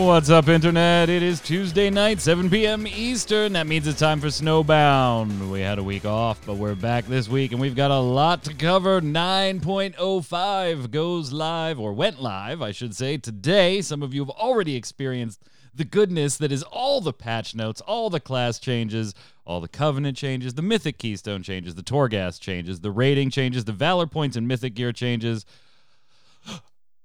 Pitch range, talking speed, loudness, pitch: 120-170 Hz, 180 wpm, -23 LUFS, 140 Hz